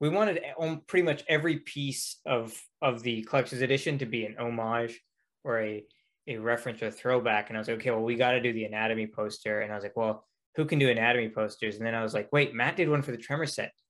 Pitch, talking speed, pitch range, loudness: 120 Hz, 255 wpm, 110-140 Hz, -30 LUFS